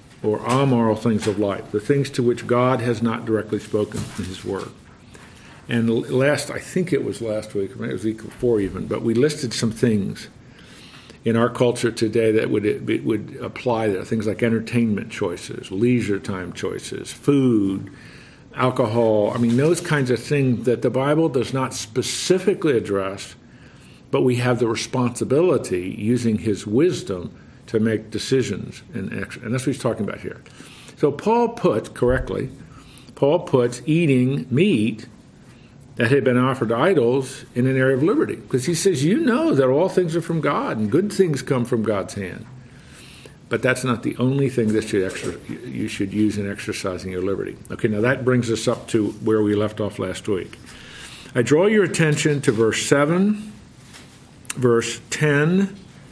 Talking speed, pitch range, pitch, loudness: 175 wpm, 110-135 Hz, 120 Hz, -21 LUFS